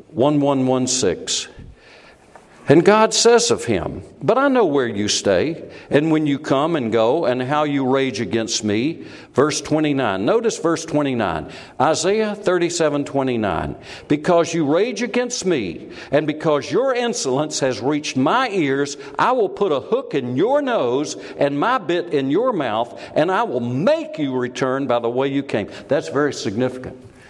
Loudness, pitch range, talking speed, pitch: -19 LUFS, 130-175 Hz, 175 wpm, 145 Hz